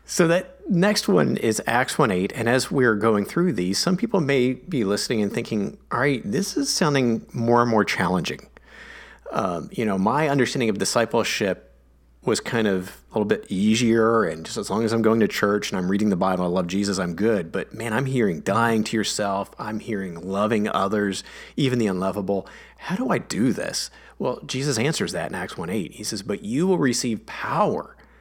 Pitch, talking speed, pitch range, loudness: 110 Hz, 200 wpm, 100-135 Hz, -23 LUFS